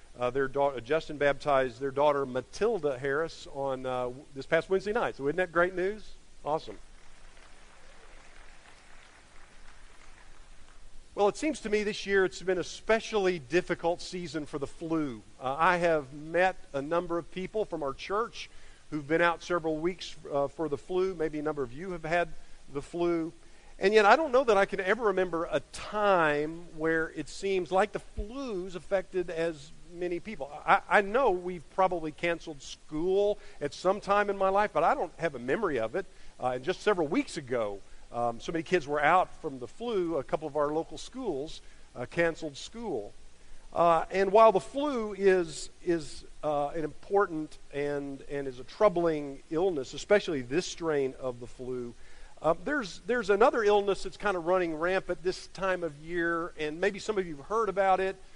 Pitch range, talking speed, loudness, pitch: 145-190 Hz, 185 wpm, -30 LUFS, 170 Hz